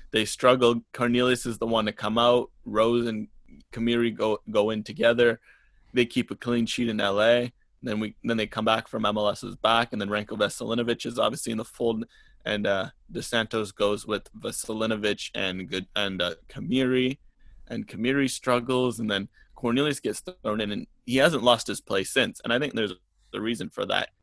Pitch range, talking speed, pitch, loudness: 105-120 Hz, 190 wpm, 115 Hz, -26 LUFS